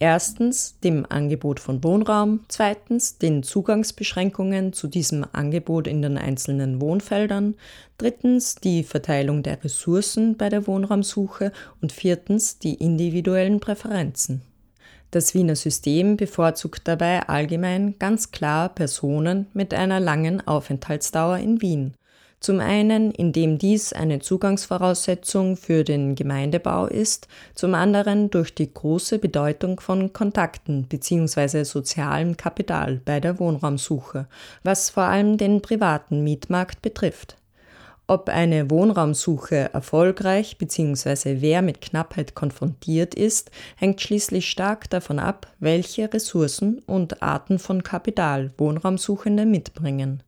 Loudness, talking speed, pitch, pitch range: -22 LUFS, 115 wpm, 175 Hz, 150-200 Hz